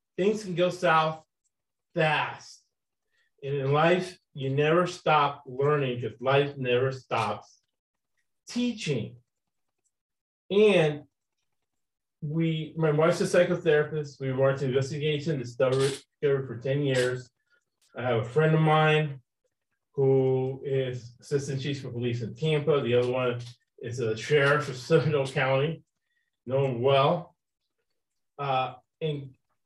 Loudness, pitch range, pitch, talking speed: -27 LUFS, 130-160 Hz, 140 Hz, 125 wpm